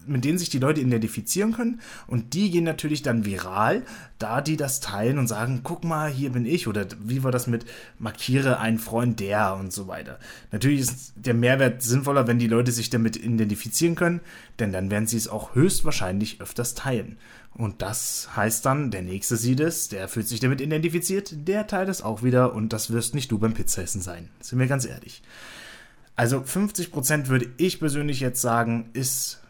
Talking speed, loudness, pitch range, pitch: 195 wpm, -25 LUFS, 110-145 Hz, 125 Hz